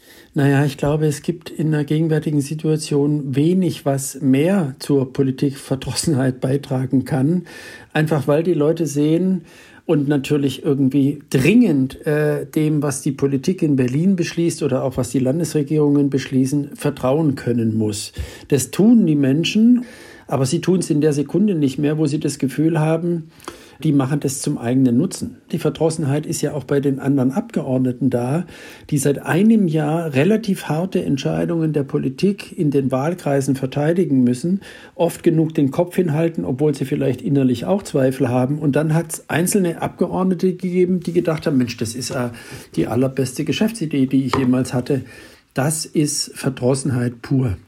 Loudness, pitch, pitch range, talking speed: -19 LUFS, 145 Hz, 135-165 Hz, 160 wpm